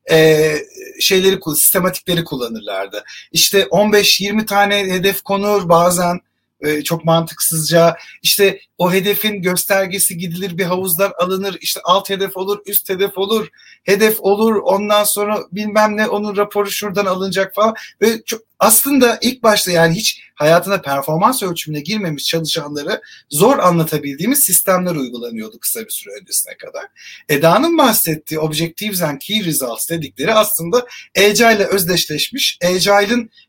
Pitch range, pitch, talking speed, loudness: 165-210 Hz, 195 Hz, 125 wpm, -15 LUFS